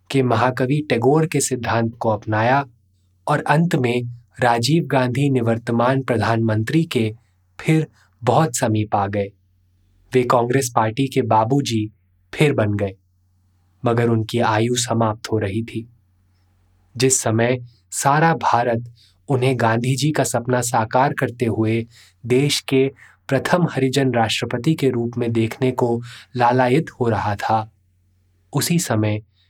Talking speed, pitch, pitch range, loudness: 130 wpm, 120 Hz, 110-130 Hz, -19 LUFS